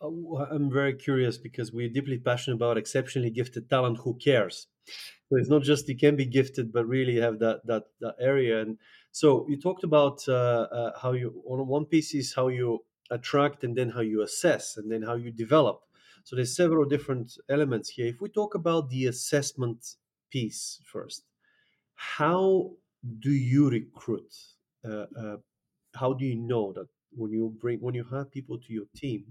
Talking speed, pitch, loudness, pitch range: 180 wpm, 130 Hz, -28 LUFS, 120-145 Hz